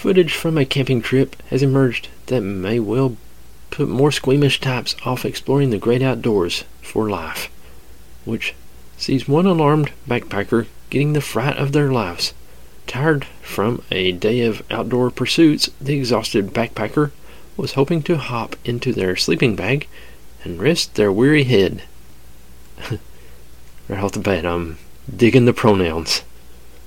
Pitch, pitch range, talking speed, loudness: 120 Hz, 85-135 Hz, 140 wpm, -18 LUFS